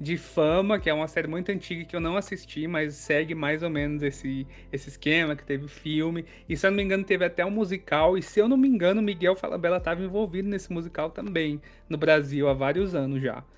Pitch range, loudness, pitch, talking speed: 150-190 Hz, -26 LUFS, 165 Hz, 235 wpm